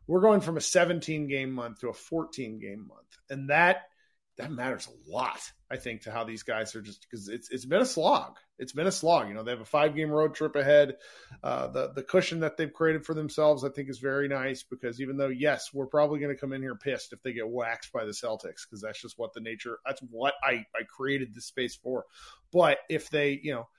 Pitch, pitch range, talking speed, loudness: 140 Hz, 125-155 Hz, 245 wpm, -29 LUFS